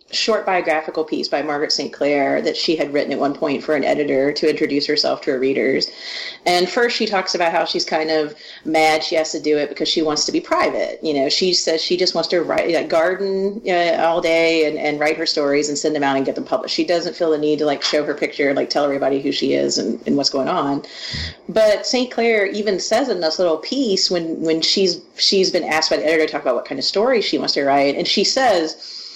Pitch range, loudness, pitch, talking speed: 150-185 Hz, -18 LUFS, 165 Hz, 260 wpm